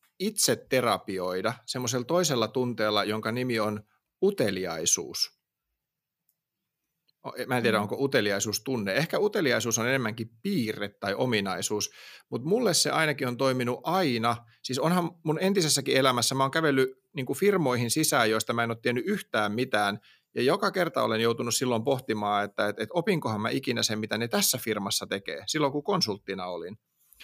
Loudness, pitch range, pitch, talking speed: -27 LUFS, 110-150 Hz, 125 Hz, 155 wpm